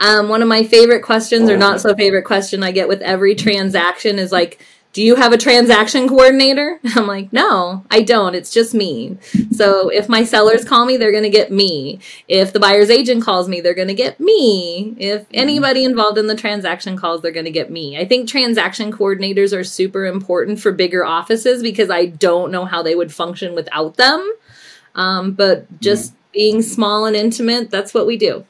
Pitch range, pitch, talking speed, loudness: 190-230 Hz, 210 Hz, 205 wpm, -14 LUFS